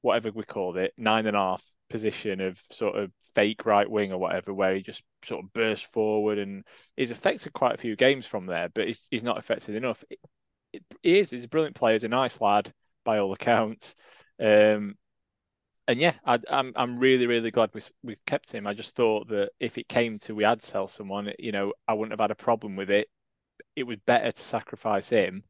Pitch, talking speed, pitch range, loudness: 105 Hz, 220 wpm, 100-115 Hz, -27 LUFS